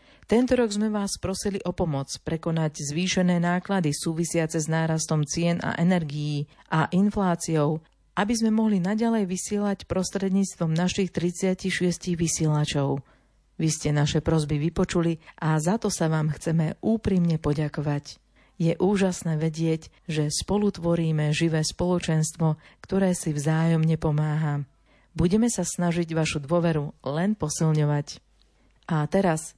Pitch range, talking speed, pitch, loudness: 155-185 Hz, 120 wpm, 165 Hz, -25 LUFS